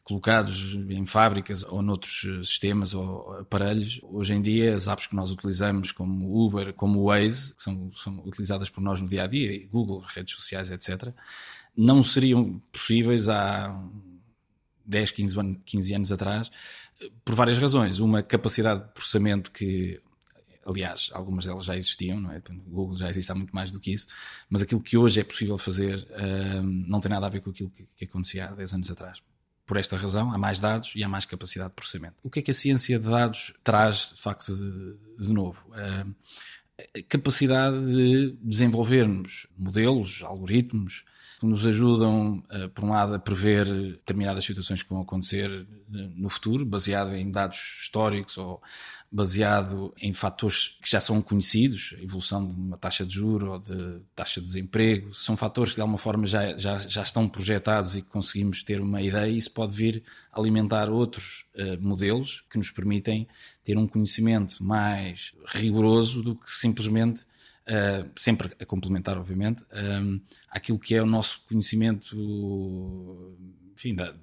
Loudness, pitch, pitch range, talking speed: -26 LUFS, 100 Hz, 95-110 Hz, 175 wpm